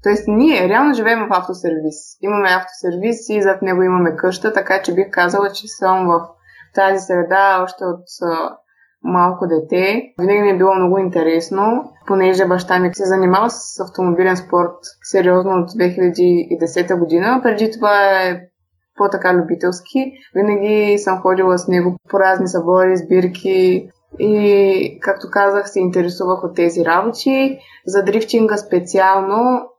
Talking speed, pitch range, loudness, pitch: 145 wpm, 180-205 Hz, -15 LUFS, 185 Hz